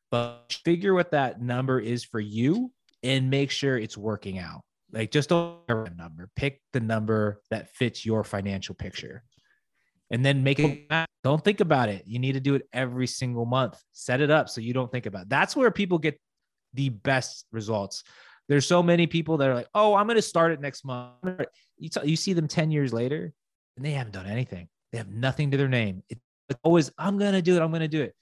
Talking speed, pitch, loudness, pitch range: 220 wpm, 135 Hz, -26 LUFS, 115-160 Hz